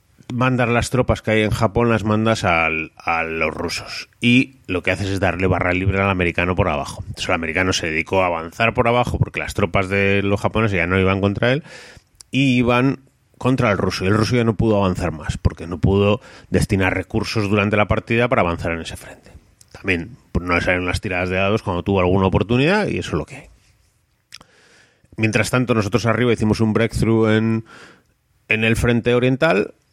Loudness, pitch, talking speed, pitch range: -19 LUFS, 105 Hz, 205 wpm, 95-115 Hz